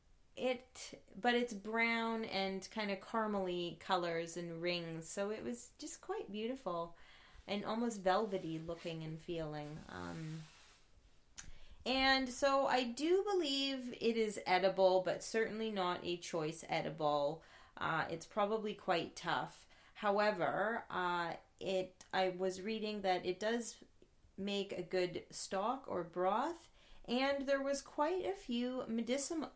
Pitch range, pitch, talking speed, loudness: 175-240 Hz, 200 Hz, 130 wpm, -38 LUFS